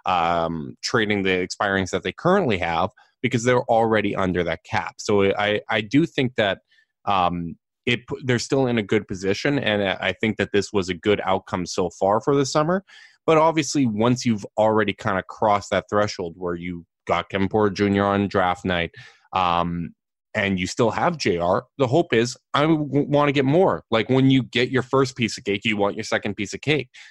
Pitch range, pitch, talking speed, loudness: 95-135 Hz, 110 Hz, 200 wpm, -22 LUFS